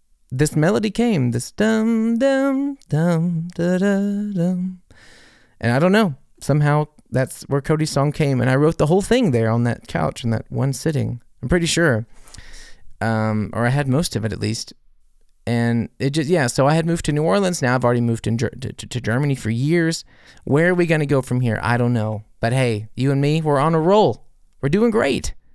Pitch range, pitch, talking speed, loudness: 120-175 Hz, 140 Hz, 220 wpm, -19 LUFS